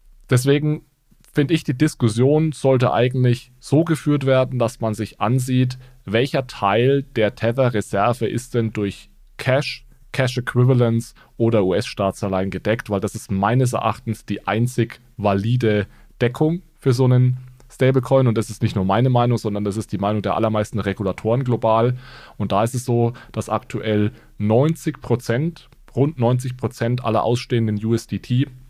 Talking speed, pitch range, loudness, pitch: 150 wpm, 110-130 Hz, -20 LUFS, 120 Hz